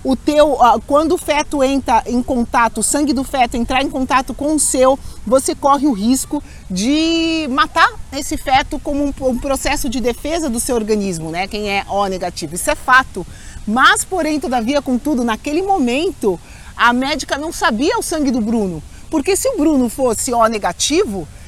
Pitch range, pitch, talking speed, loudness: 240-300 Hz, 270 Hz, 180 wpm, -16 LUFS